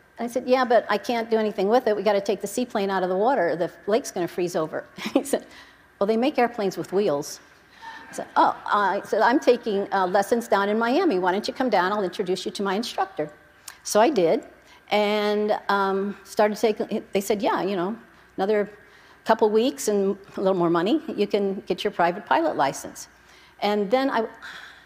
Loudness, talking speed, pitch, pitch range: -24 LUFS, 215 wpm, 210 Hz, 195-230 Hz